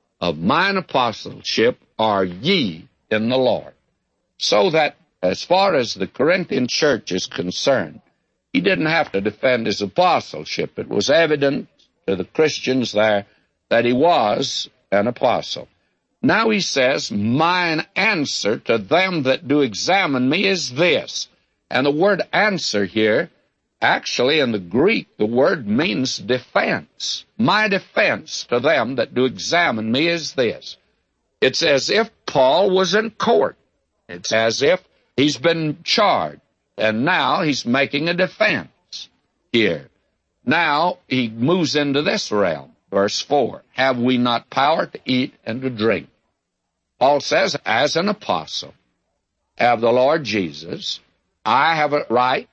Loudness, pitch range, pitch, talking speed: -19 LUFS, 115-165 Hz, 130 Hz, 140 wpm